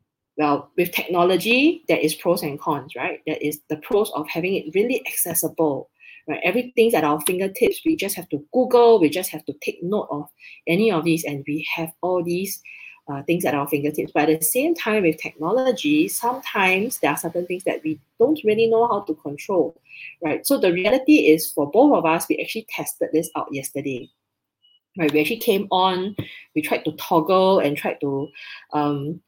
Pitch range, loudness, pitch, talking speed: 150-220 Hz, -21 LUFS, 170 Hz, 195 wpm